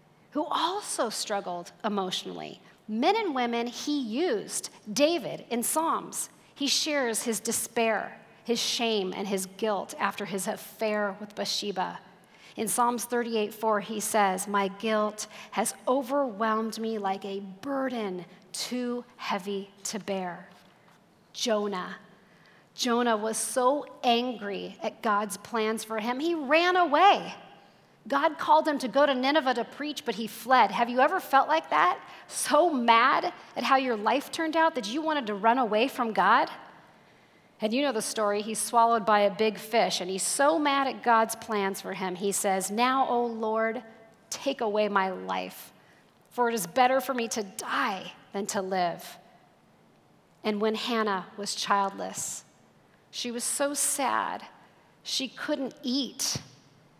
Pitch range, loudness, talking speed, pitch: 200-255 Hz, -28 LUFS, 150 wpm, 225 Hz